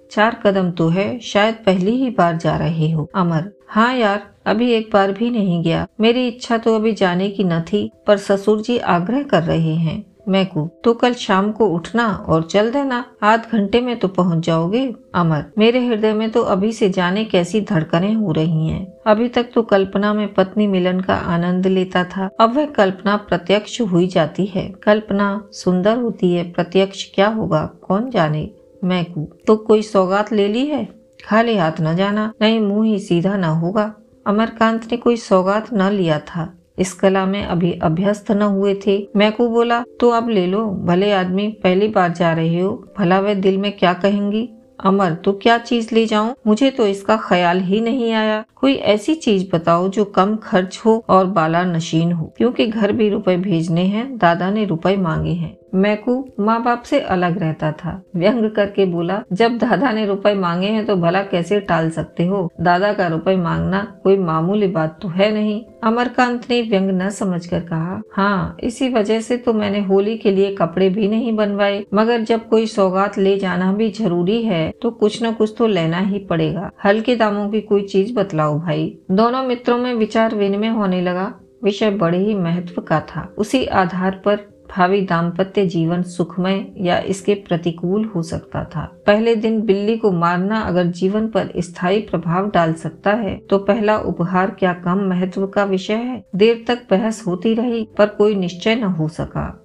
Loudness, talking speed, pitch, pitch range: -18 LUFS, 190 wpm, 200 Hz, 180-220 Hz